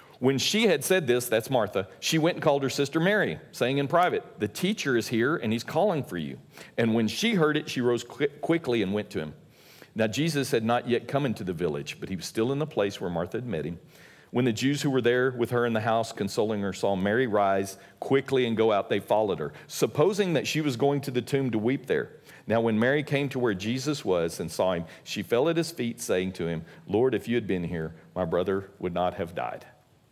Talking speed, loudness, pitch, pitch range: 250 wpm, -27 LUFS, 125 Hz, 110-145 Hz